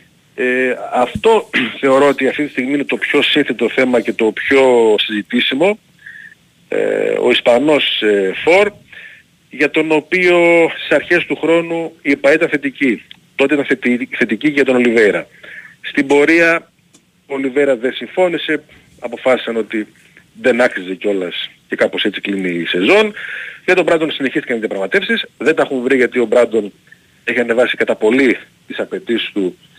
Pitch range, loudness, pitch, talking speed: 120-165 Hz, -14 LUFS, 140 Hz, 150 wpm